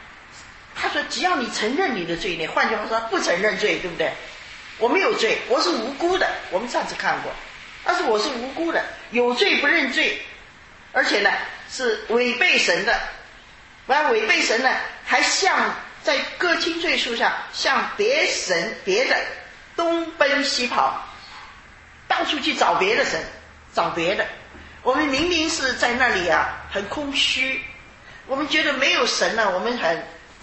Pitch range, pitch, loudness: 245-350 Hz, 295 Hz, -21 LUFS